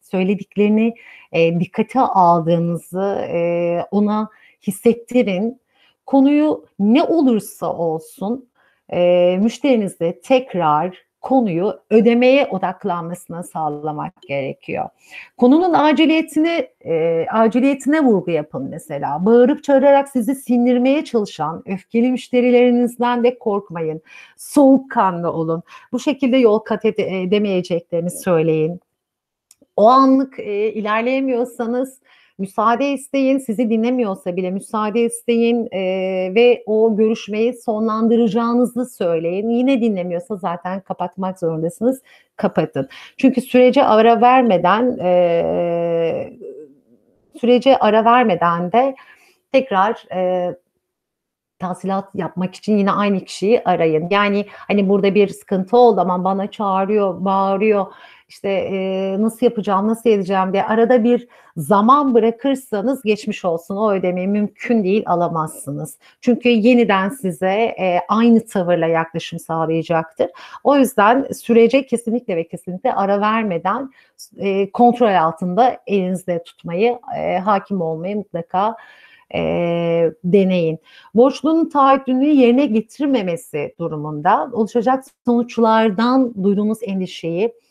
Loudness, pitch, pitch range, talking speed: -17 LUFS, 210 Hz, 180-245 Hz, 100 wpm